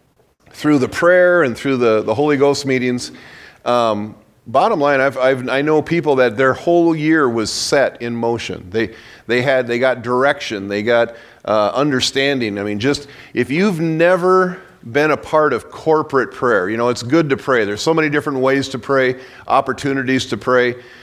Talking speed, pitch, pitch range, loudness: 185 wpm, 130 Hz, 120-145 Hz, -16 LUFS